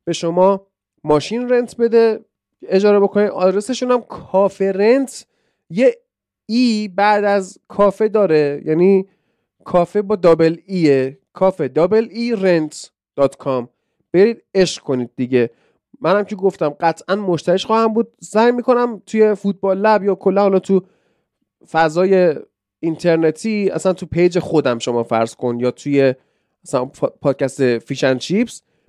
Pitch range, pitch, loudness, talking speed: 155-210 Hz, 190 Hz, -17 LUFS, 130 wpm